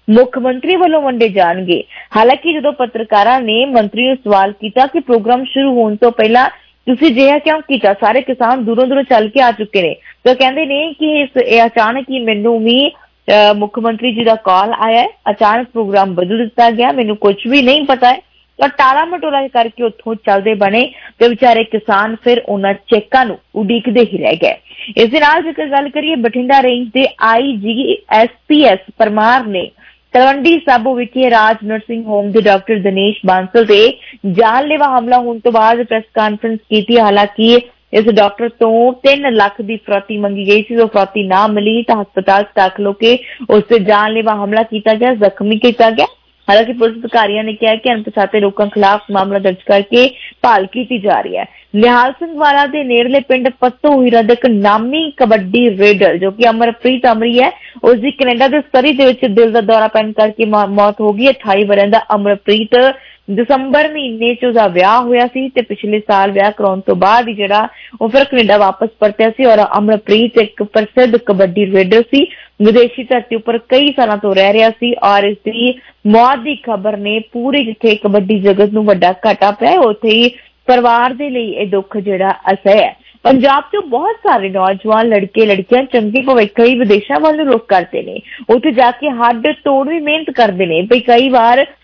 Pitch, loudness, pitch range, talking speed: 230 Hz, -11 LUFS, 210-255 Hz, 175 wpm